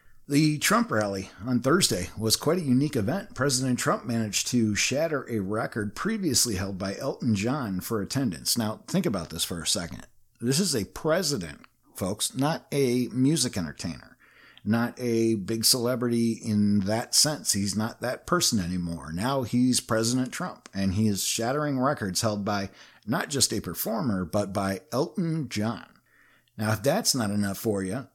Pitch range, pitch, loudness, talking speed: 105-130 Hz, 115 Hz, -26 LUFS, 165 wpm